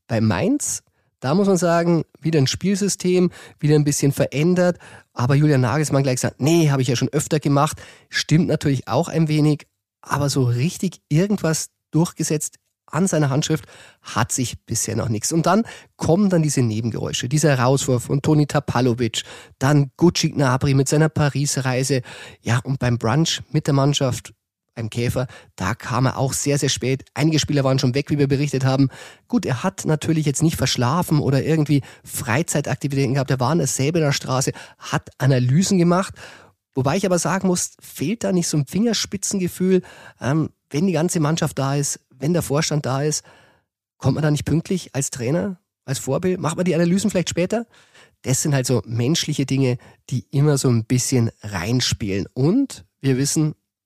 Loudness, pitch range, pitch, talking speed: -20 LUFS, 125-160 Hz, 140 Hz, 175 wpm